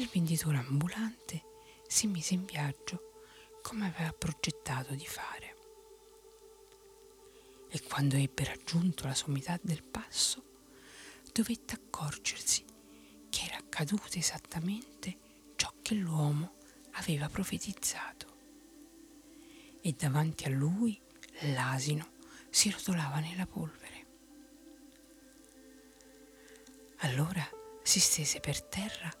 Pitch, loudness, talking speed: 180 Hz, -34 LUFS, 90 wpm